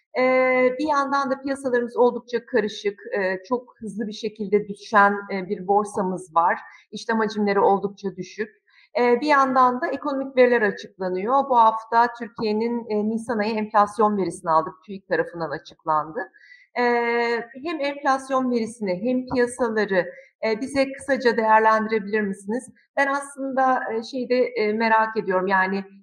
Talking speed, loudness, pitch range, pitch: 135 wpm, -22 LUFS, 205-255 Hz, 225 Hz